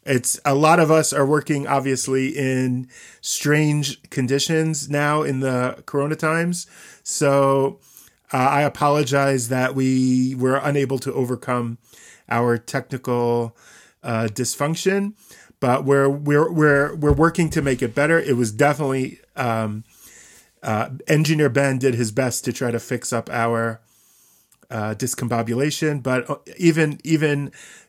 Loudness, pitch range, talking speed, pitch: -20 LUFS, 125-150 Hz, 130 wpm, 135 Hz